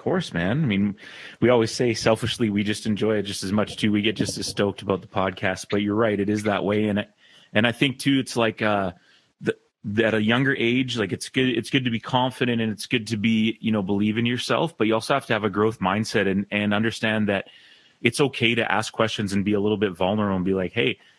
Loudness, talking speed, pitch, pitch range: -23 LUFS, 260 wpm, 110 Hz, 100-115 Hz